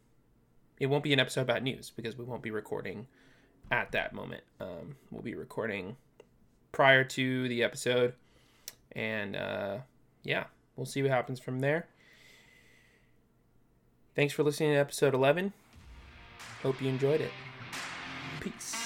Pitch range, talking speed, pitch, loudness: 115-140 Hz, 135 wpm, 130 Hz, -32 LUFS